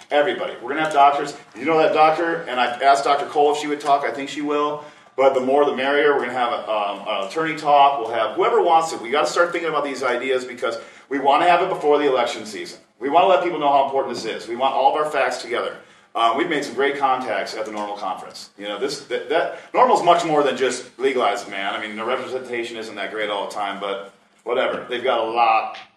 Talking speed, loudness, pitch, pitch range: 260 wpm, -20 LUFS, 145 Hz, 130-160 Hz